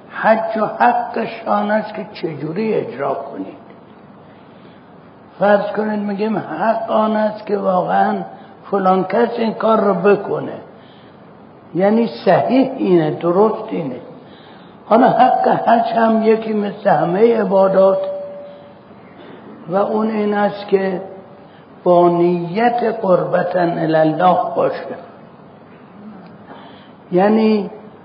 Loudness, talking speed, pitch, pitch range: -16 LUFS, 100 wpm, 205 Hz, 190-220 Hz